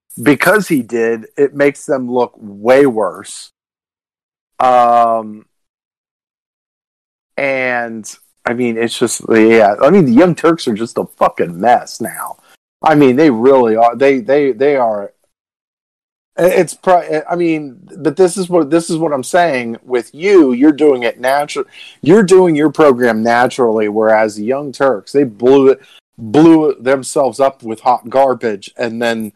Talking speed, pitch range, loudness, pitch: 155 wpm, 115-160 Hz, -12 LUFS, 135 Hz